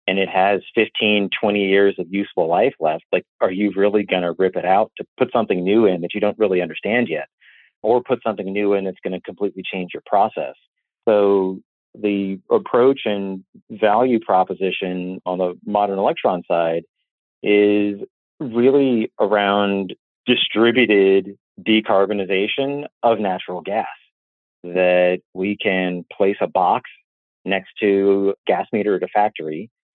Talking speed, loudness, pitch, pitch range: 150 wpm, -19 LUFS, 100 Hz, 95-105 Hz